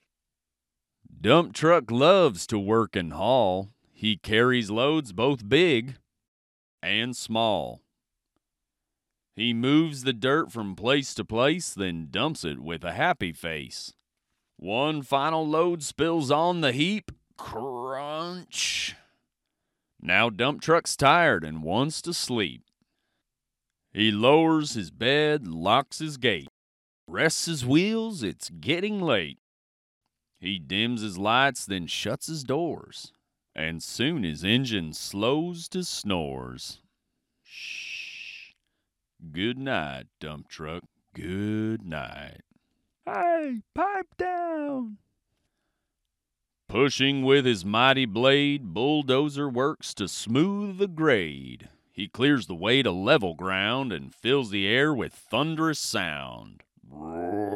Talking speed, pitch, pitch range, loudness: 115 wpm, 125 Hz, 95-155 Hz, -25 LUFS